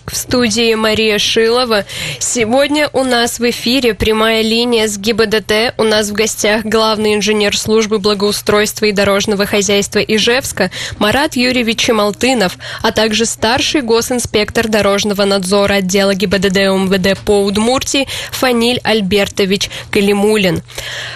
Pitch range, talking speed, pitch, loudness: 205-230 Hz, 120 wpm, 215 Hz, -12 LUFS